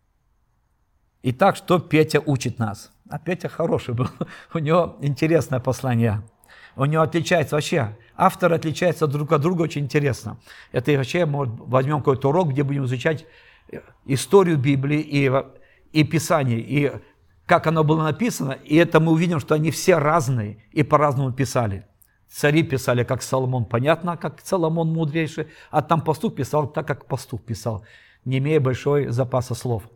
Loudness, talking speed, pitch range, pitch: -21 LUFS, 150 wpm, 130-160 Hz, 145 Hz